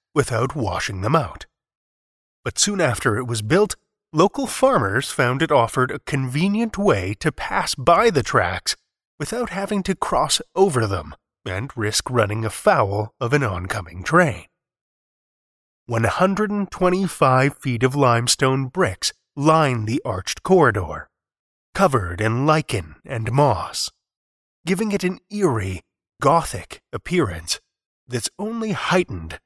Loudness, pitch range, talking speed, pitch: -20 LUFS, 110-185 Hz, 120 wpm, 135 Hz